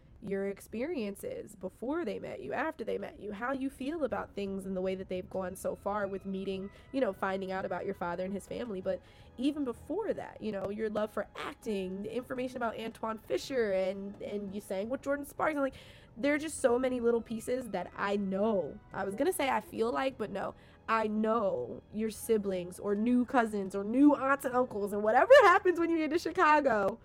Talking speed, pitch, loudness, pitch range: 215 wpm, 220 Hz, -32 LUFS, 195-265 Hz